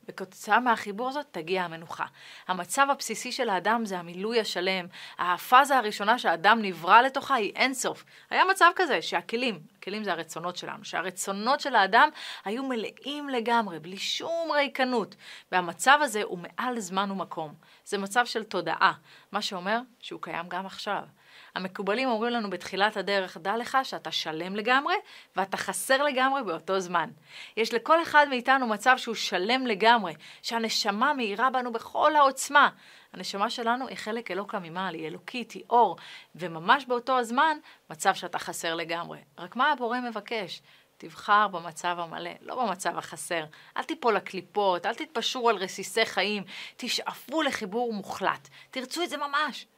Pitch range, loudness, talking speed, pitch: 185-255 Hz, -27 LUFS, 145 wpm, 215 Hz